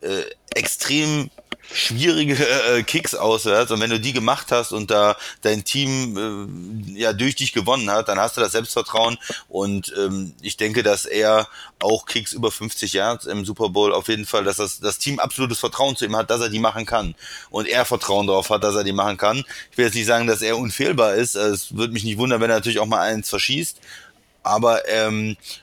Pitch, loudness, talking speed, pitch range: 110 Hz, -20 LUFS, 215 wpm, 105-120 Hz